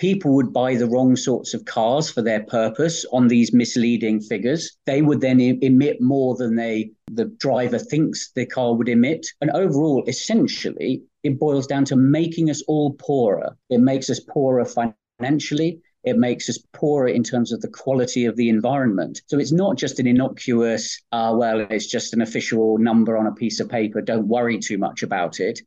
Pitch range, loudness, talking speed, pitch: 115-140 Hz, -20 LUFS, 190 wpm, 125 Hz